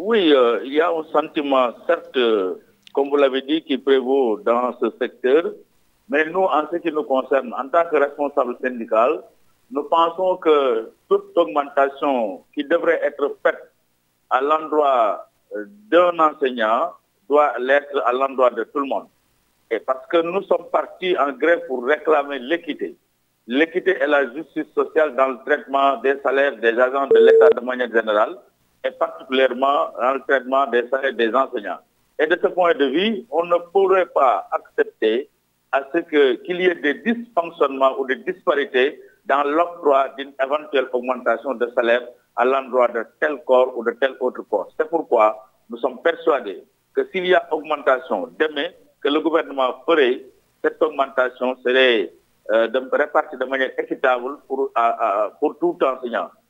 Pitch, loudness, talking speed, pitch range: 145 Hz, -20 LUFS, 165 wpm, 130-180 Hz